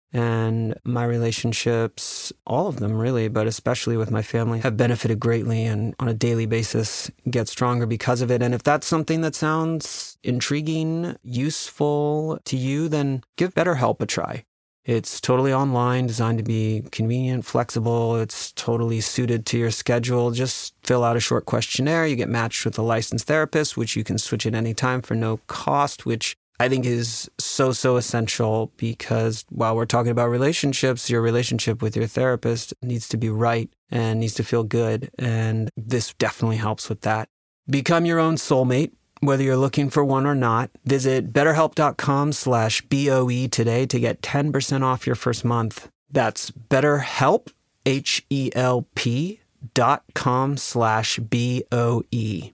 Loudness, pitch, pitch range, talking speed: -22 LUFS, 120 Hz, 115-135 Hz, 160 wpm